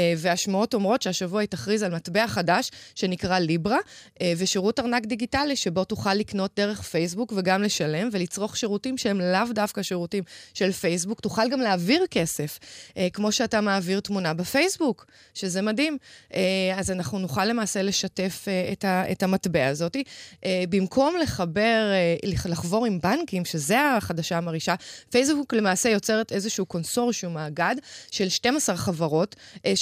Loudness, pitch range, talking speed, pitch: -25 LUFS, 180-225 Hz, 130 wpm, 195 Hz